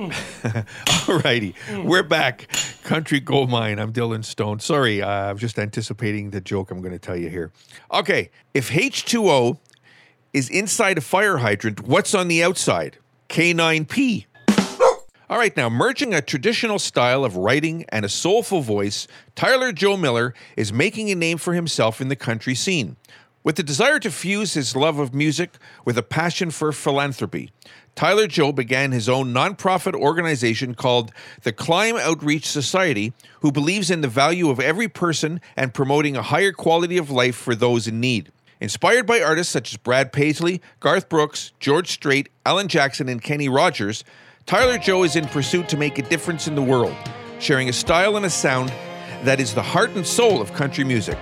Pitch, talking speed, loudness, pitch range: 145 Hz, 175 wpm, -20 LUFS, 120-175 Hz